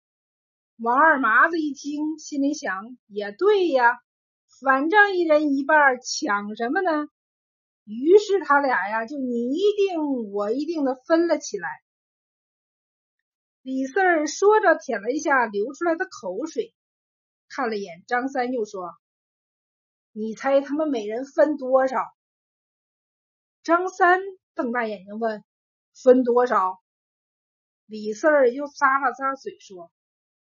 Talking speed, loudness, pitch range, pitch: 170 characters per minute, -22 LUFS, 240-330 Hz, 275 Hz